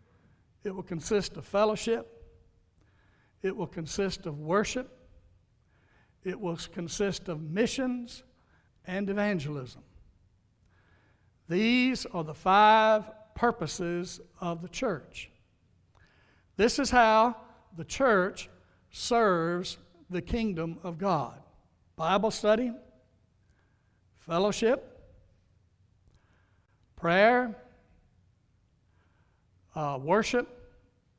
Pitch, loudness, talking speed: 155 Hz, -29 LUFS, 80 wpm